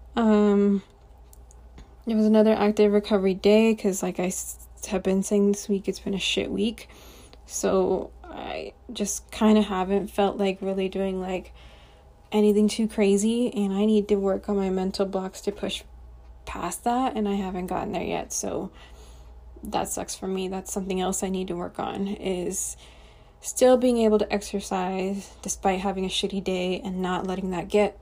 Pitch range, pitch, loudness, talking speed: 185-205 Hz, 195 Hz, -25 LUFS, 175 wpm